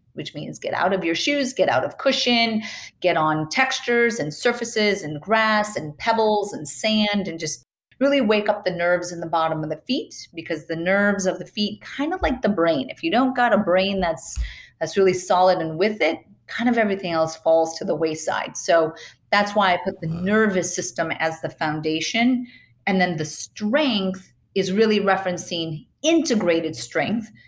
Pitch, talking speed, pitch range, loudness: 190 Hz, 190 wpm, 165-225 Hz, -22 LUFS